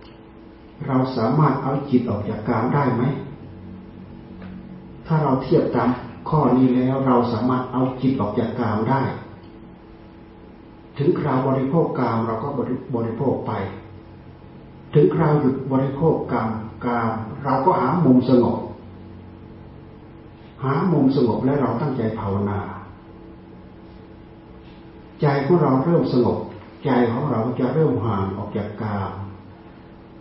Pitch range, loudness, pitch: 110-135 Hz, -21 LUFS, 120 Hz